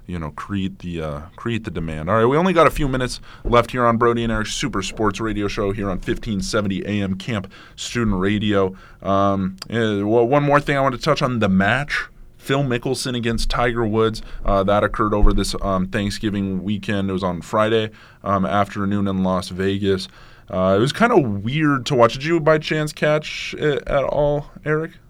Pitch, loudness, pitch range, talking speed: 110 Hz, -20 LUFS, 100-125 Hz, 200 wpm